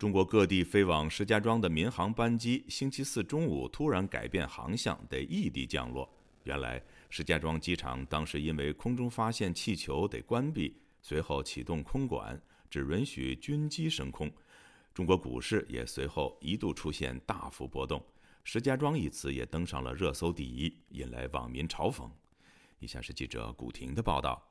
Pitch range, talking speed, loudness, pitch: 65-105 Hz, 260 characters per minute, -34 LUFS, 80 Hz